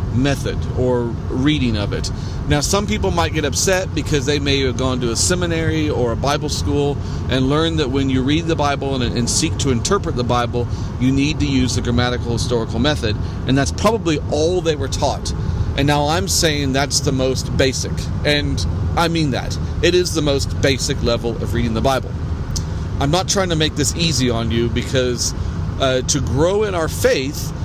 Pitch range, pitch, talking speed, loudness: 100-135 Hz, 120 Hz, 195 wpm, -18 LUFS